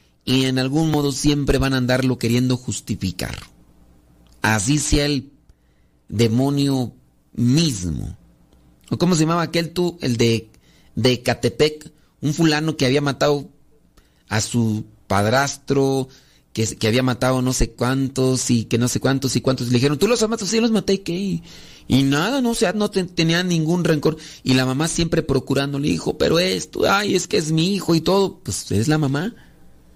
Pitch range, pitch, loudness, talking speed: 115-155 Hz, 135 Hz, -20 LUFS, 175 wpm